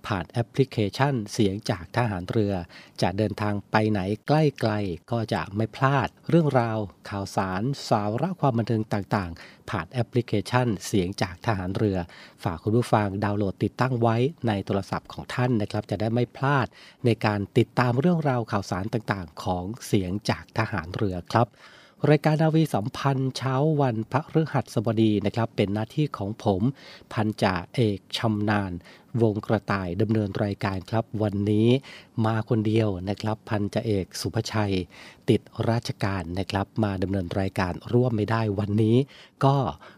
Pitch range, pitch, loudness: 100-125 Hz, 110 Hz, -26 LUFS